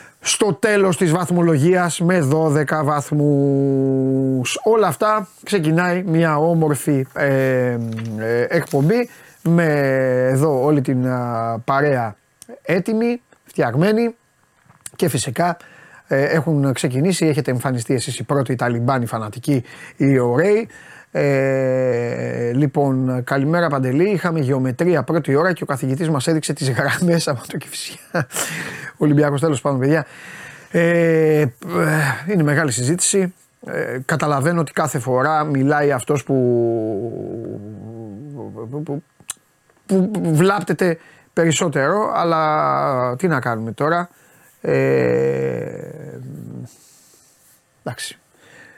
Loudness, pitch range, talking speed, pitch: -18 LUFS, 130-170 Hz, 100 wpm, 145 Hz